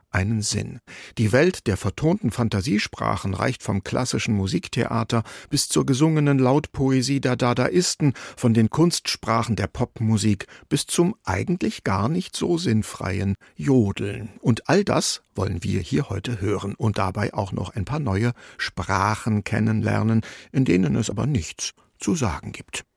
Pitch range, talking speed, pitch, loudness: 105-130 Hz, 145 wpm, 110 Hz, -23 LUFS